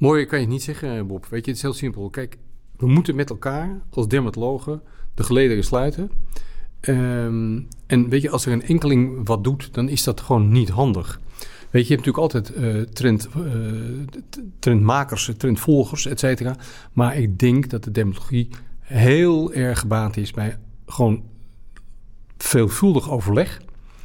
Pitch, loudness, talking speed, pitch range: 125 Hz, -21 LUFS, 165 wpm, 110-135 Hz